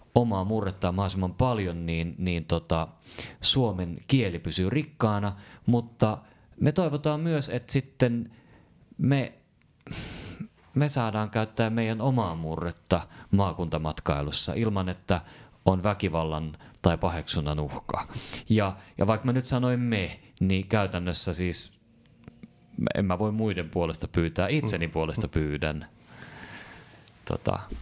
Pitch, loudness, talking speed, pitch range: 100 Hz, -28 LUFS, 110 wpm, 85-120 Hz